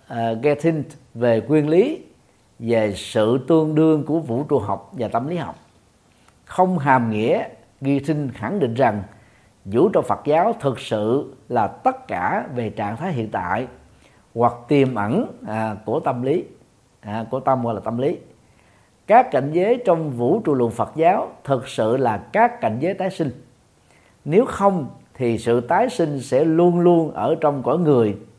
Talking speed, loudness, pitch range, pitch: 170 wpm, -20 LUFS, 115-160 Hz, 135 Hz